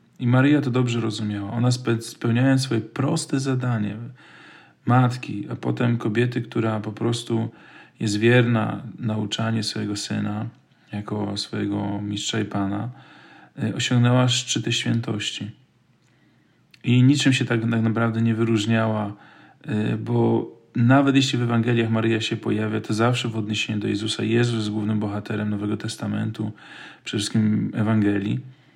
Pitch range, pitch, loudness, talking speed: 105-120 Hz, 115 Hz, -23 LUFS, 125 wpm